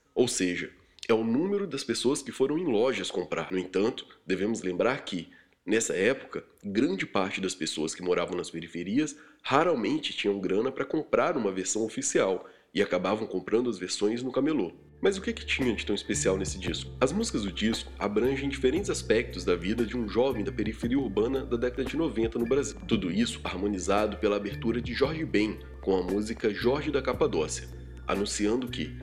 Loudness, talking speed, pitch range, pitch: -29 LUFS, 185 wpm, 90-120 Hz, 100 Hz